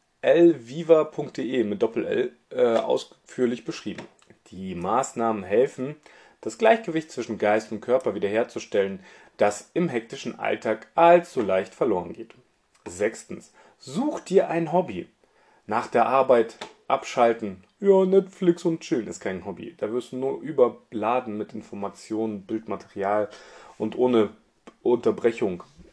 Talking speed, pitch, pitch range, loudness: 125 wpm, 135 Hz, 110-175 Hz, -24 LUFS